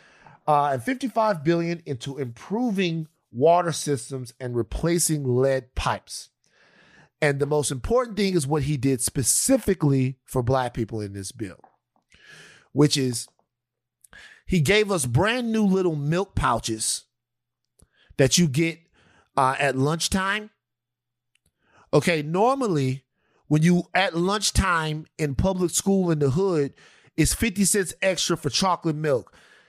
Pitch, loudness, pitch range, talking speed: 150 Hz, -23 LUFS, 130-180 Hz, 125 wpm